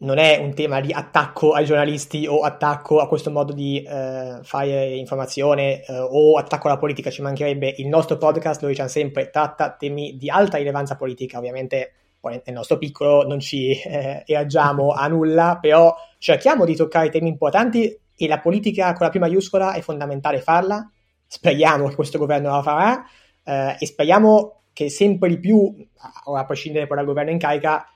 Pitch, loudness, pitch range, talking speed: 150 Hz, -19 LUFS, 140-165 Hz, 180 wpm